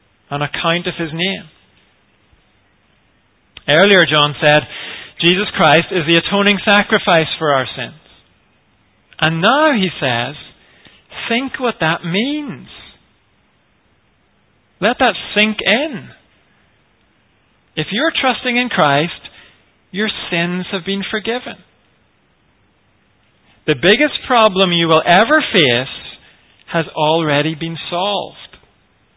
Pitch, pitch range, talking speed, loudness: 175 Hz, 155-210 Hz, 105 wpm, -14 LUFS